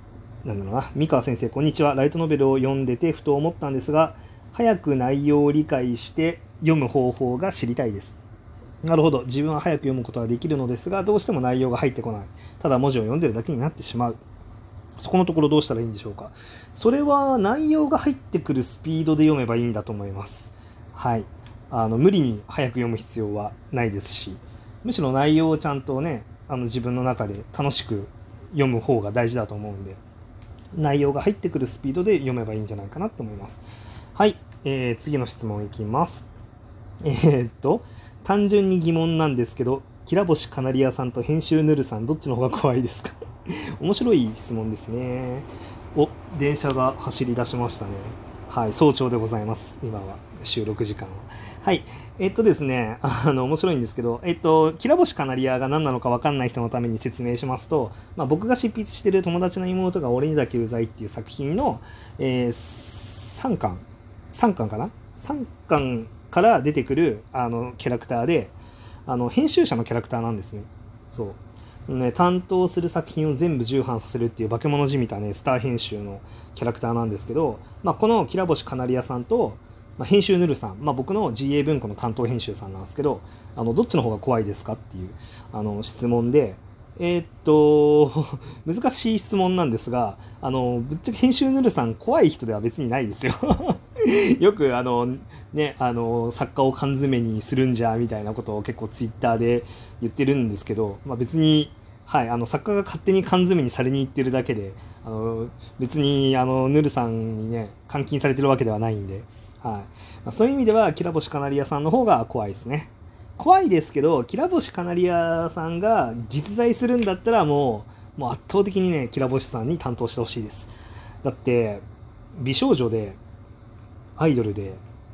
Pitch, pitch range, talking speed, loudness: 125 Hz, 110-150 Hz, 380 characters per minute, -23 LUFS